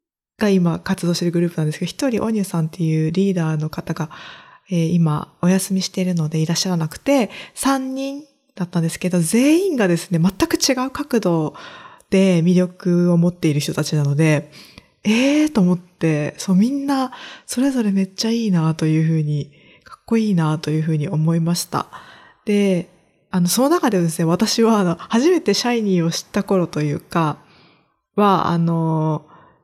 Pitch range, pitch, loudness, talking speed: 165-225 Hz, 180 Hz, -19 LUFS, 350 characters per minute